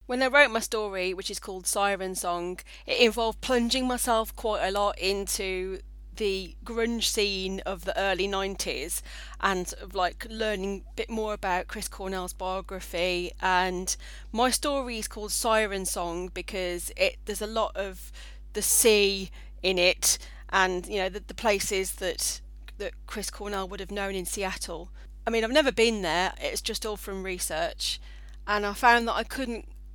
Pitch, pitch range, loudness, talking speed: 195 Hz, 185-225 Hz, -27 LUFS, 170 wpm